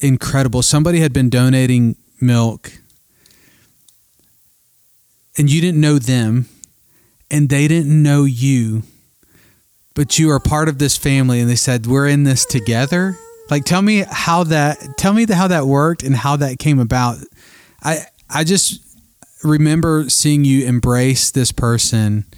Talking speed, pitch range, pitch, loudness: 145 wpm, 125-155 Hz, 140 Hz, -14 LUFS